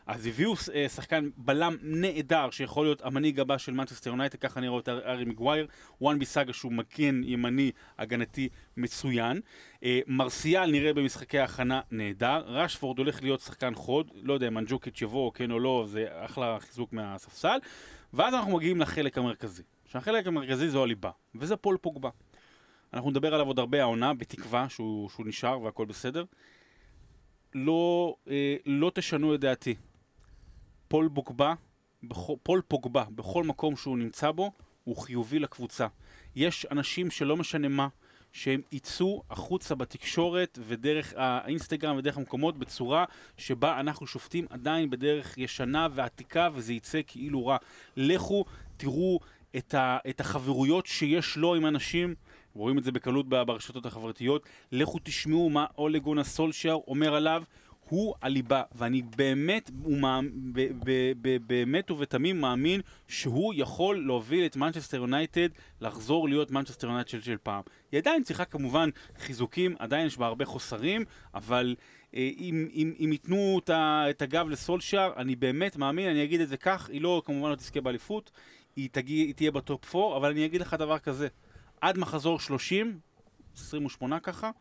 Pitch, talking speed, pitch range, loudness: 140 Hz, 145 wpm, 125-155 Hz, -30 LUFS